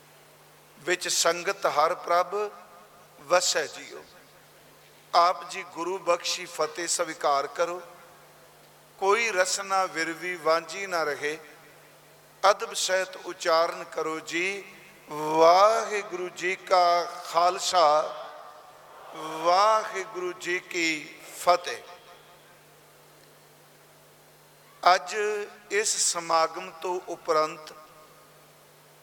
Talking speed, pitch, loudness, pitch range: 80 wpm, 175 Hz, -26 LUFS, 160-185 Hz